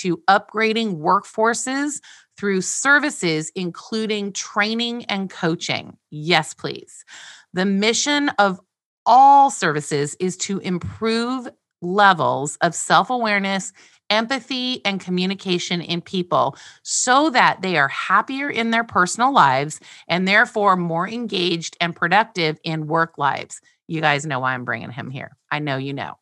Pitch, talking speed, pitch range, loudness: 190 Hz, 135 wpm, 165-225 Hz, -19 LUFS